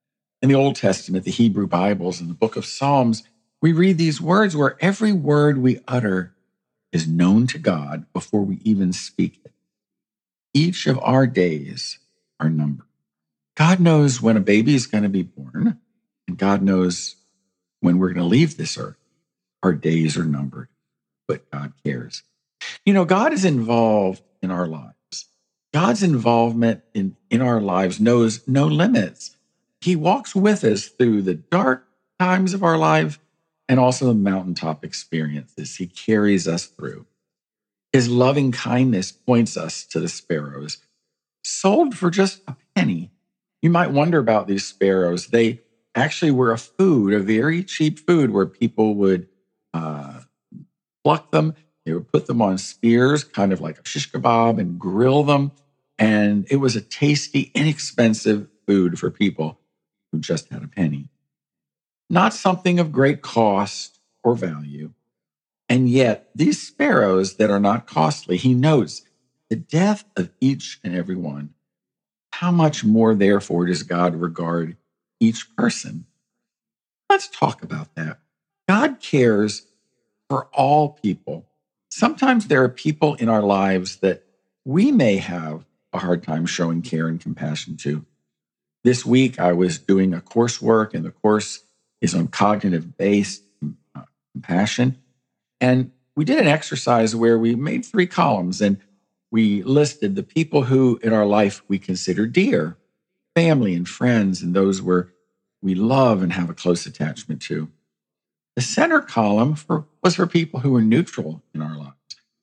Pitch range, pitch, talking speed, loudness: 90-140 Hz, 110 Hz, 155 wpm, -20 LUFS